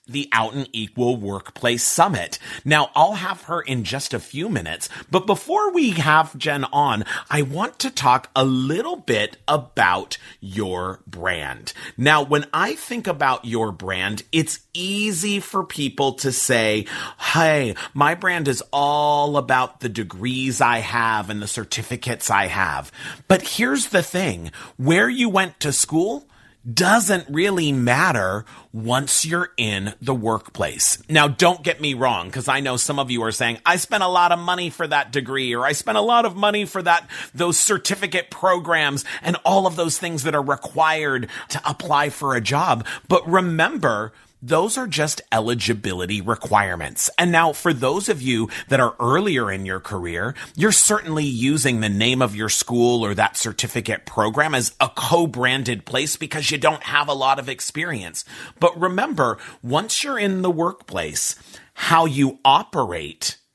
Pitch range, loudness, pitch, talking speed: 120-175 Hz, -20 LUFS, 140 Hz, 165 wpm